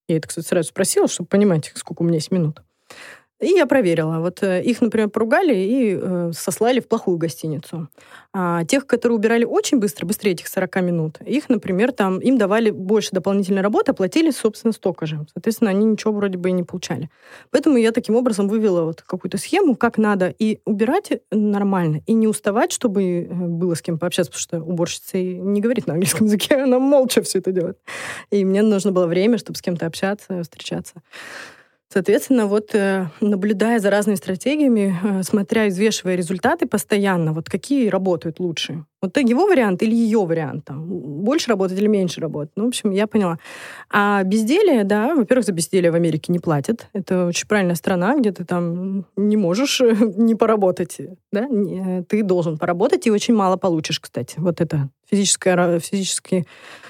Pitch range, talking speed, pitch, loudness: 175-225 Hz, 175 wpm, 195 Hz, -19 LUFS